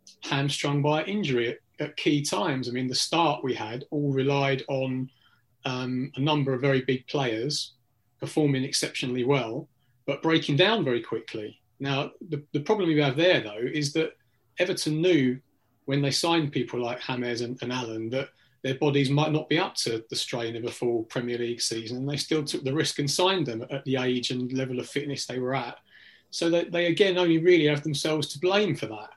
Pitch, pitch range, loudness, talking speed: 140 Hz, 125-155 Hz, -27 LUFS, 200 wpm